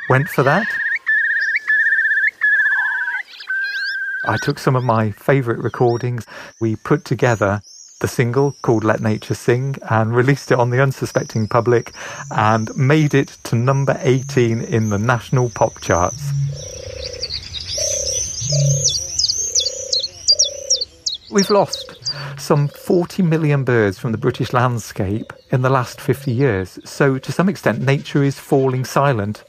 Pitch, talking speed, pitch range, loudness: 135 Hz, 120 wpm, 120-160 Hz, -18 LUFS